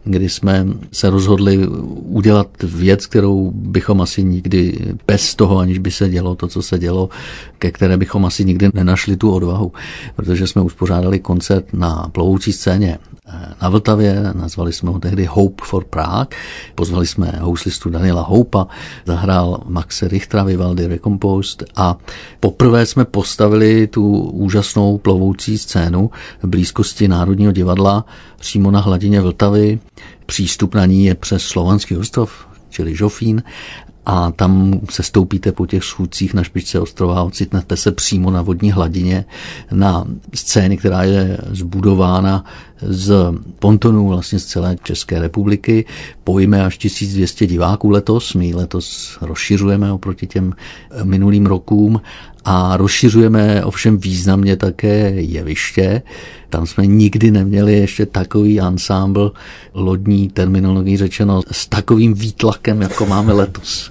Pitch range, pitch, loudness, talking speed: 90-105 Hz, 95 Hz, -15 LUFS, 135 wpm